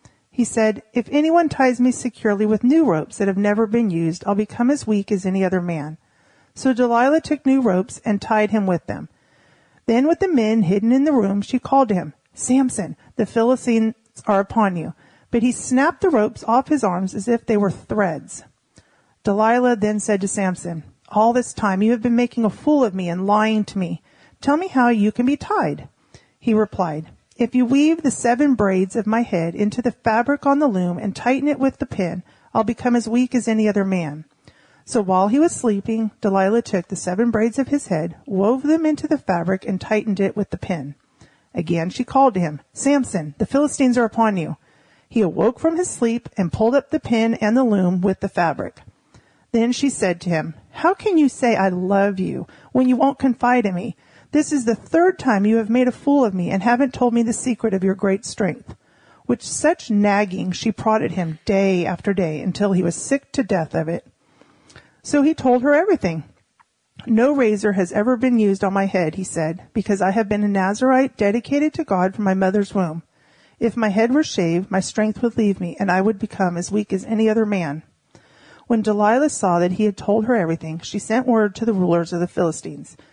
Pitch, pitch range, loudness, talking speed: 215 Hz, 190-245 Hz, -19 LUFS, 215 wpm